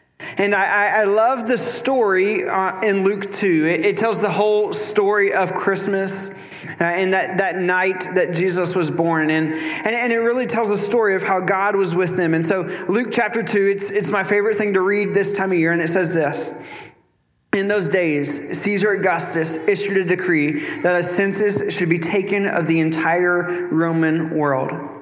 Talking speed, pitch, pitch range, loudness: 190 wpm, 190 Hz, 175-205 Hz, -19 LUFS